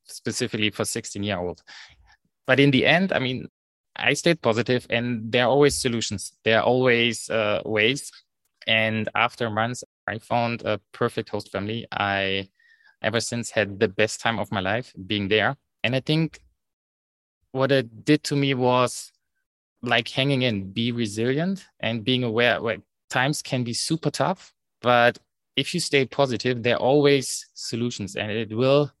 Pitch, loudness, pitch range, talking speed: 120 Hz, -23 LUFS, 110-130 Hz, 160 wpm